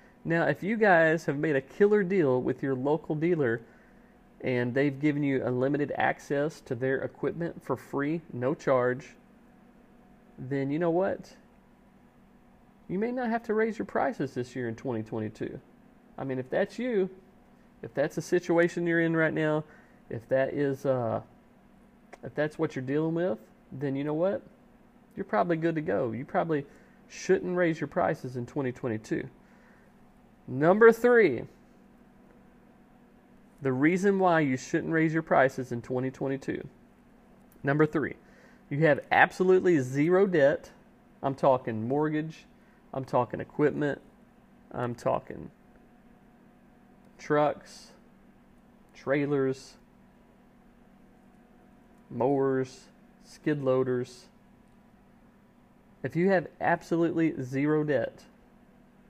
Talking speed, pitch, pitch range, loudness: 120 wpm, 170 Hz, 140-230 Hz, -28 LUFS